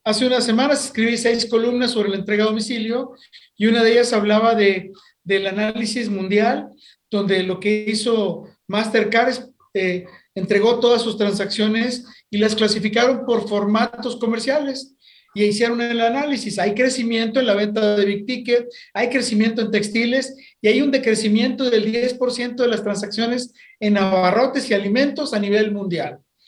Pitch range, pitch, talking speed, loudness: 210-245 Hz, 225 Hz, 155 wpm, -19 LUFS